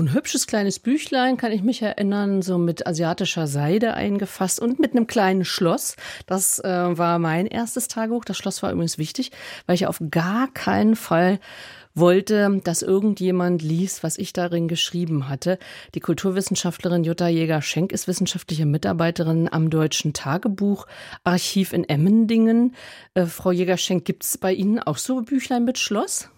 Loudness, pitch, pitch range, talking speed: -22 LUFS, 185 Hz, 170-225 Hz, 155 wpm